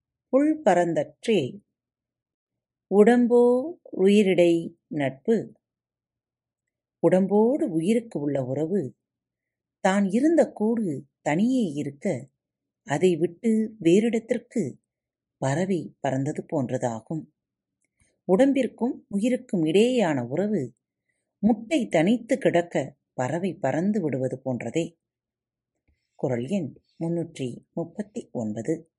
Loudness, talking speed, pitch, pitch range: -25 LUFS, 75 wpm, 170 Hz, 135-225 Hz